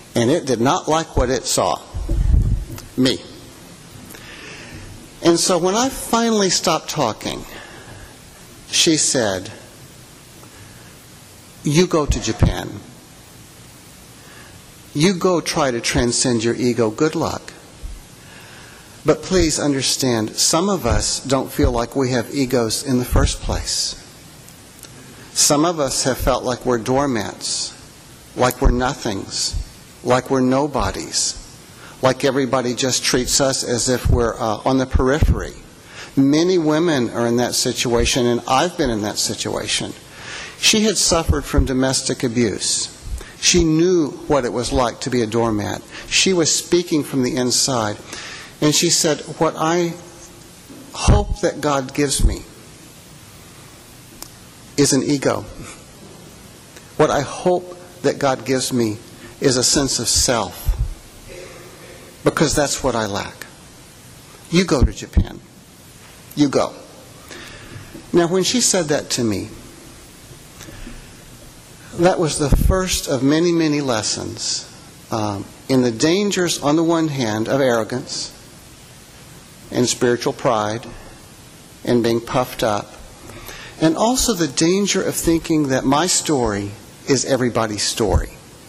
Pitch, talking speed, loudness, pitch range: 135 Hz, 125 wpm, -18 LUFS, 120-160 Hz